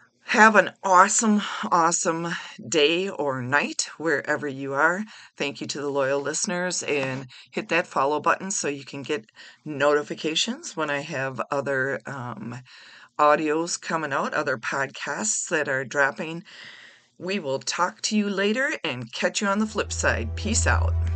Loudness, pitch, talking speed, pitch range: -24 LUFS, 155 Hz, 155 wpm, 140-185 Hz